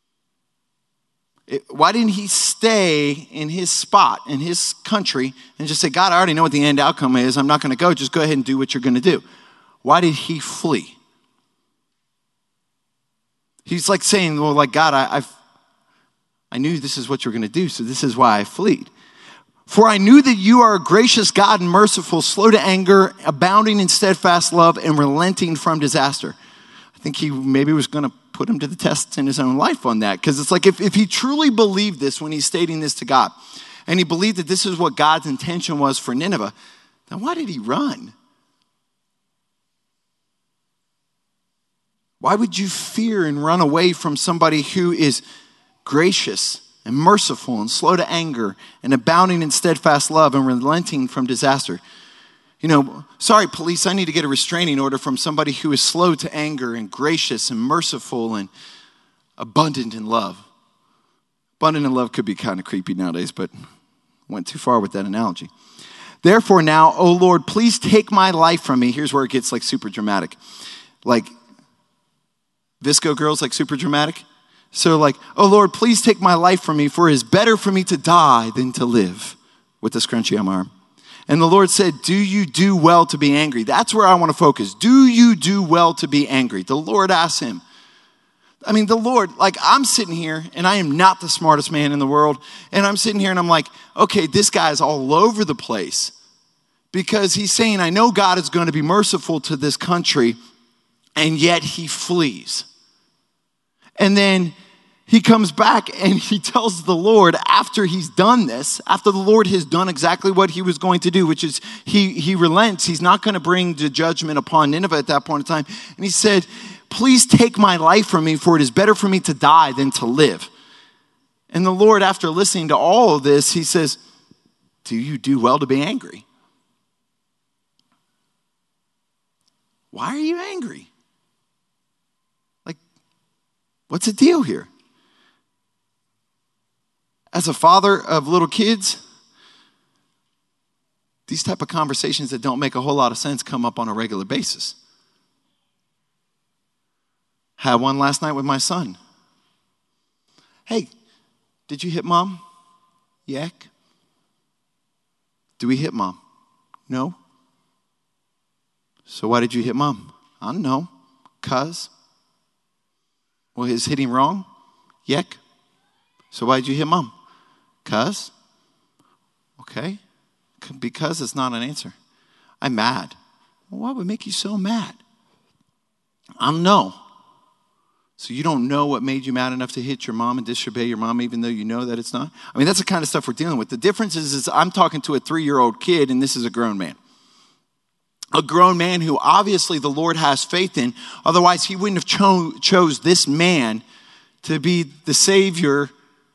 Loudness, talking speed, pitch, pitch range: -17 LUFS, 180 wpm, 170 Hz, 140-200 Hz